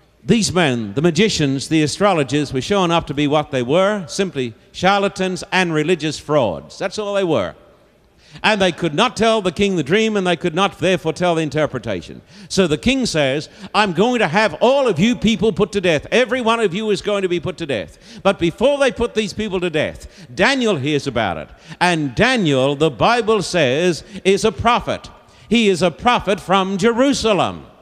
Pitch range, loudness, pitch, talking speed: 160-210 Hz, -17 LUFS, 190 Hz, 200 wpm